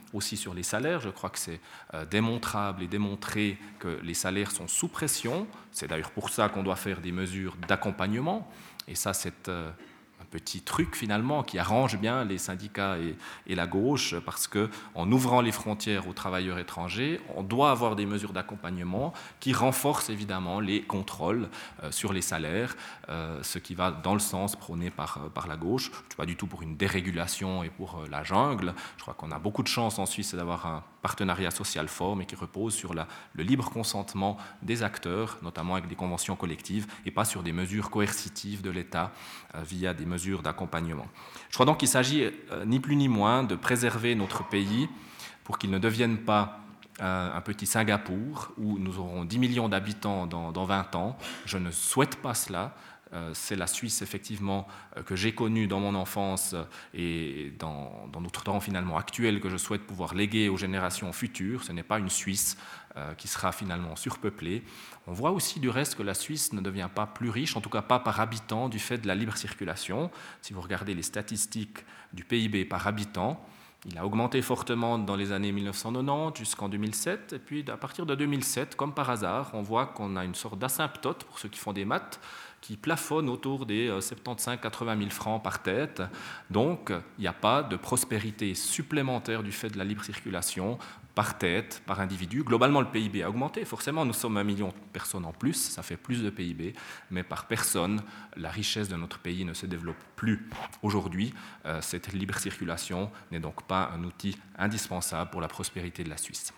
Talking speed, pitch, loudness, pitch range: 195 wpm, 100 Hz, -31 LUFS, 90-110 Hz